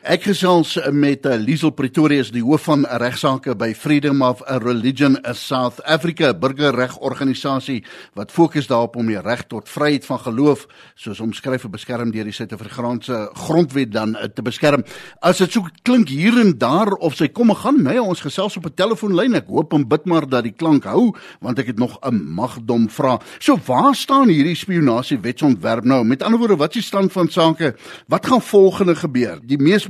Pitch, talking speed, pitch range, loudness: 145 Hz, 195 wpm, 125-175 Hz, -17 LUFS